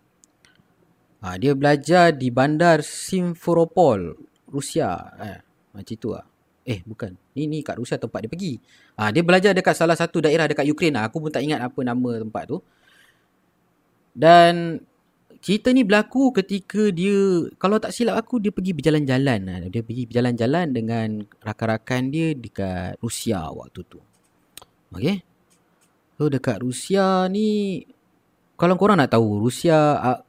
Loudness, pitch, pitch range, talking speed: -21 LUFS, 150 Hz, 115-180 Hz, 135 wpm